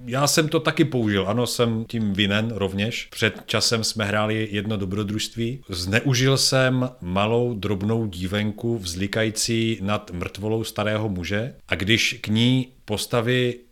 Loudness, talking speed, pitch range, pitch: -23 LUFS, 135 wpm, 105-120 Hz, 110 Hz